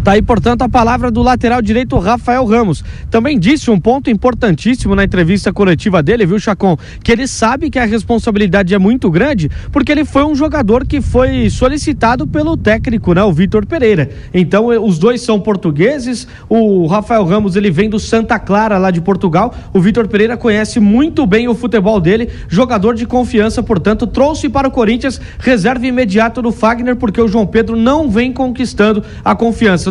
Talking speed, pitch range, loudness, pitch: 180 wpm, 205-245 Hz, -12 LUFS, 225 Hz